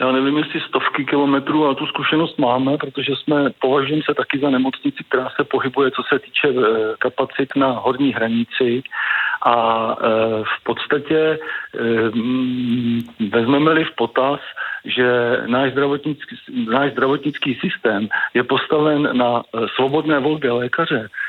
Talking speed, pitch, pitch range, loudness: 125 wpm, 140 Hz, 125-150 Hz, -18 LUFS